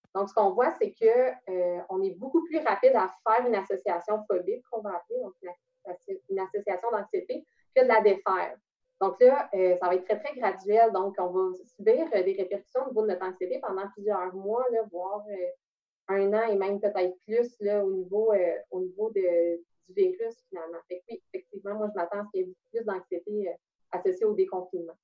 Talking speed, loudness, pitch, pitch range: 210 wpm, -28 LUFS, 205 Hz, 185-270 Hz